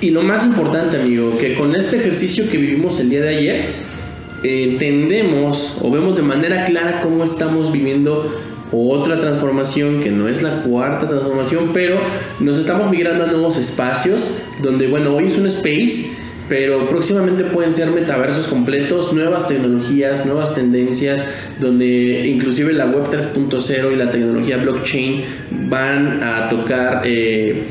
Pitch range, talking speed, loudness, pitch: 130-165 Hz, 150 wpm, -16 LUFS, 140 Hz